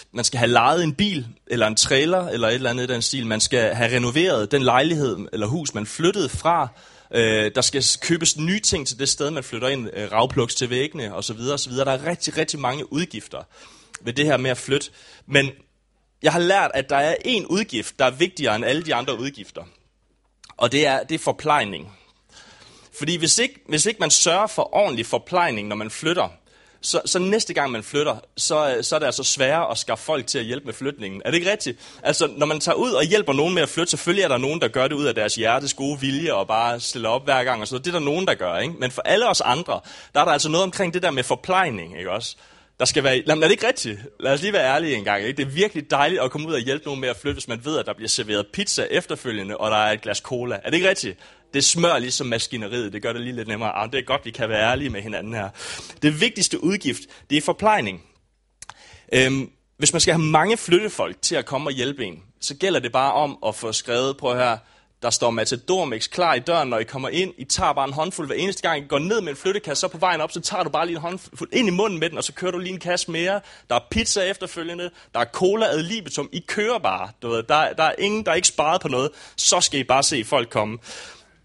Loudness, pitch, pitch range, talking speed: -21 LUFS, 140 Hz, 120-170 Hz, 255 wpm